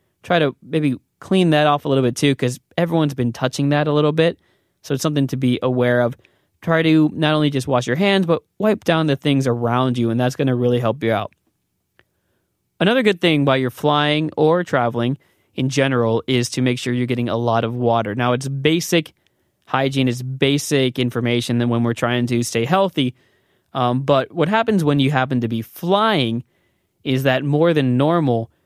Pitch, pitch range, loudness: 135 Hz, 120-155 Hz, -19 LUFS